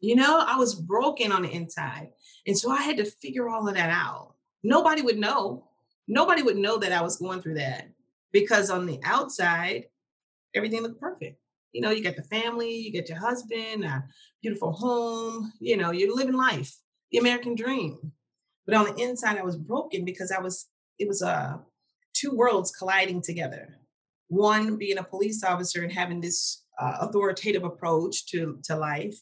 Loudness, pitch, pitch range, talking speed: -26 LUFS, 200 Hz, 175-230 Hz, 185 wpm